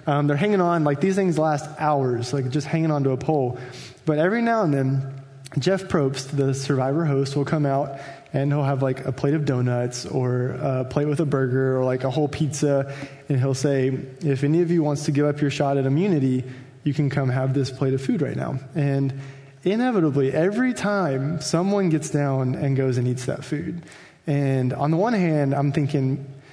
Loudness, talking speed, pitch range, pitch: -23 LUFS, 210 wpm, 135-155 Hz, 140 Hz